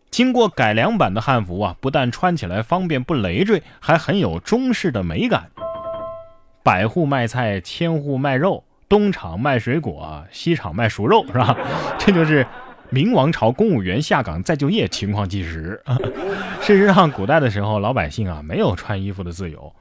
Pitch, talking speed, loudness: 140 Hz, 260 characters per minute, -19 LUFS